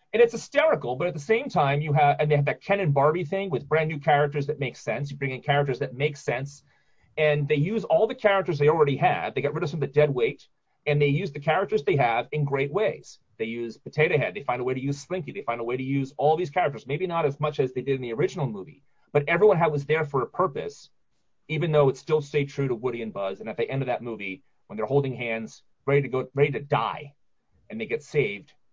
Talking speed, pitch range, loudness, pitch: 270 wpm, 135-165 Hz, -25 LUFS, 145 Hz